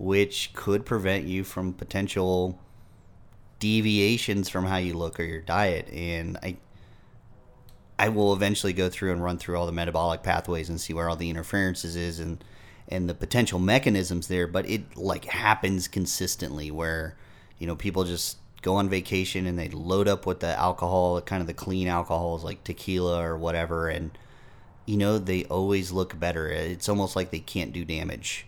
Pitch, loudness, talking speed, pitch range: 90 Hz, -27 LUFS, 175 wpm, 85-100 Hz